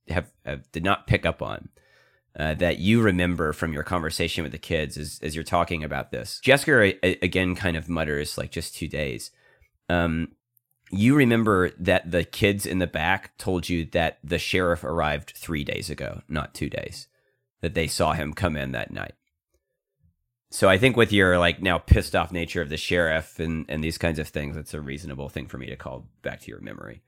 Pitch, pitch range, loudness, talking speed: 85 Hz, 75-90 Hz, -24 LUFS, 205 wpm